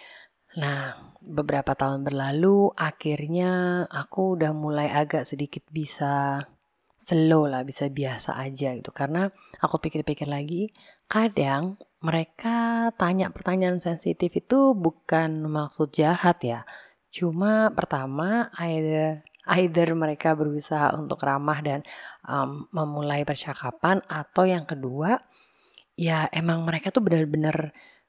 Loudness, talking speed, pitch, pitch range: -26 LUFS, 110 wpm, 155 Hz, 145-180 Hz